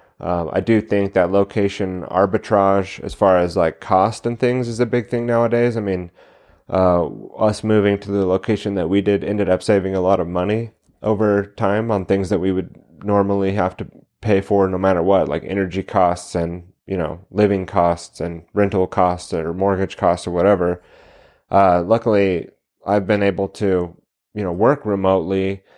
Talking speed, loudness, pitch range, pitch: 180 wpm, -19 LUFS, 90-105 Hz, 100 Hz